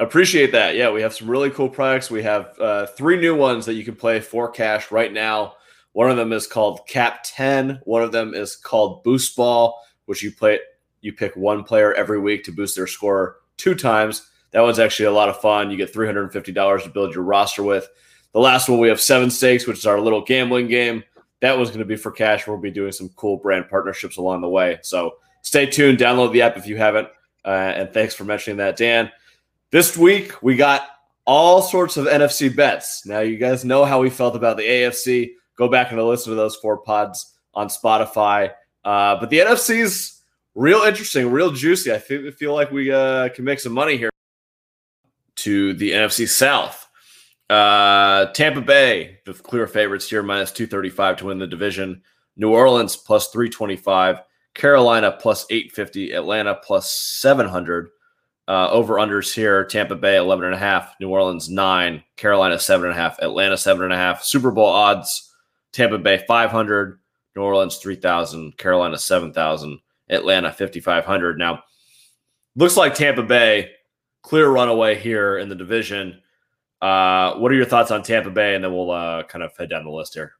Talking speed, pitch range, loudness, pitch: 185 wpm, 100-130 Hz, -18 LUFS, 110 Hz